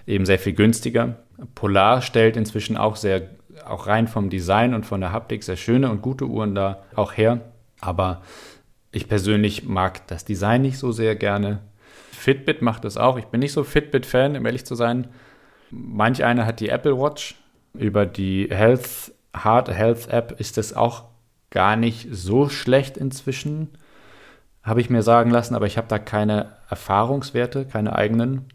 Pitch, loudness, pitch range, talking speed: 115 Hz, -21 LUFS, 105-125 Hz, 170 wpm